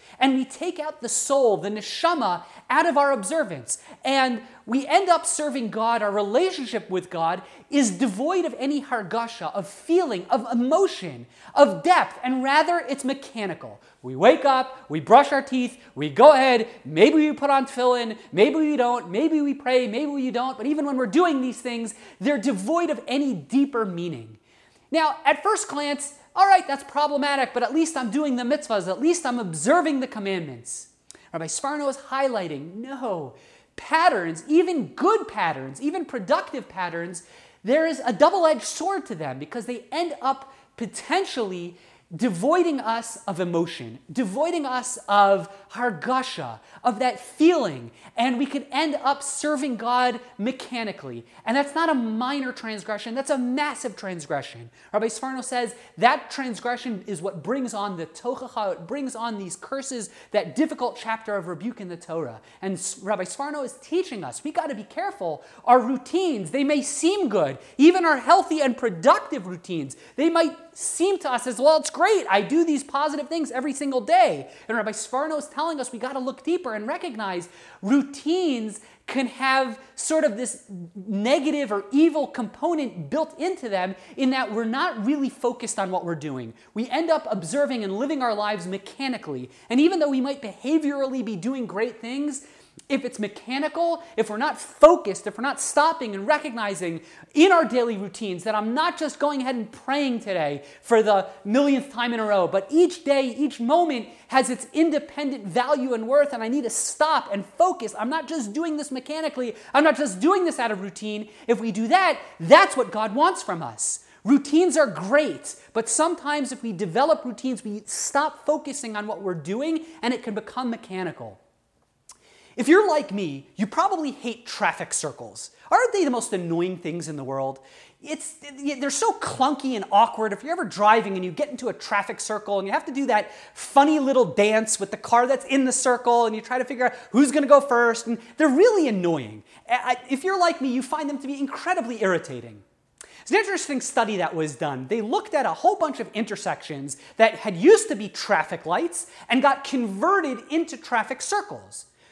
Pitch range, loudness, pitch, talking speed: 210-295 Hz, -23 LUFS, 255 Hz, 185 wpm